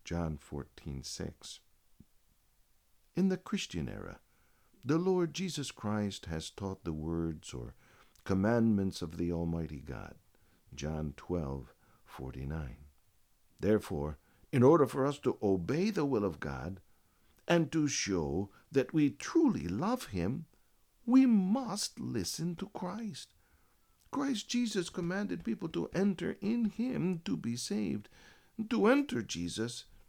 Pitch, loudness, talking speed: 115 Hz, -34 LUFS, 120 wpm